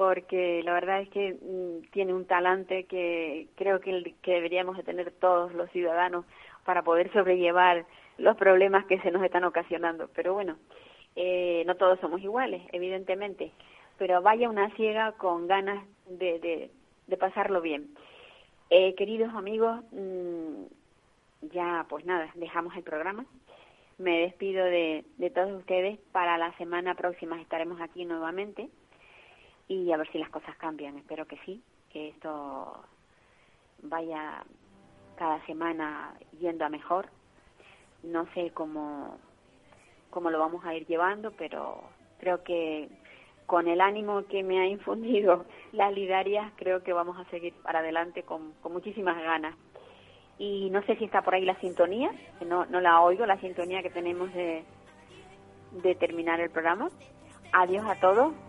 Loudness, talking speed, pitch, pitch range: -29 LUFS, 150 wpm, 180 Hz, 170-190 Hz